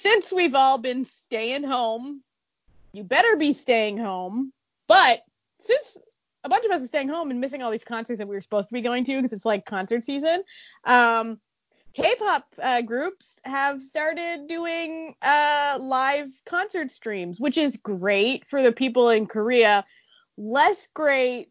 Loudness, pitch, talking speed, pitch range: -23 LUFS, 265 Hz, 165 wpm, 230-315 Hz